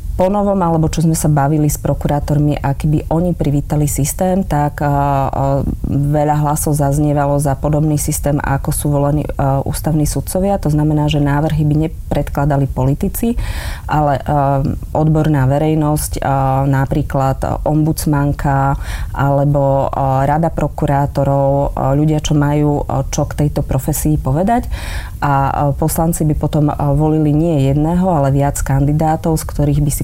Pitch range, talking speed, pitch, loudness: 140-155 Hz, 125 wpm, 145 Hz, -15 LUFS